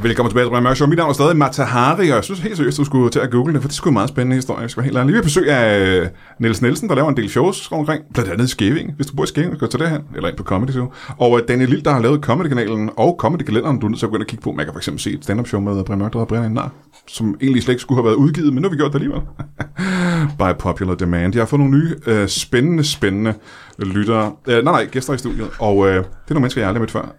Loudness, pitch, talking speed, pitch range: -17 LUFS, 125 Hz, 300 wpm, 110-145 Hz